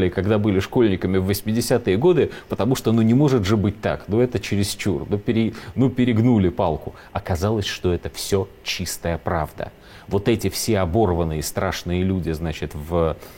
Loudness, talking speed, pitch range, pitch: -21 LUFS, 160 wpm, 90-115 Hz, 100 Hz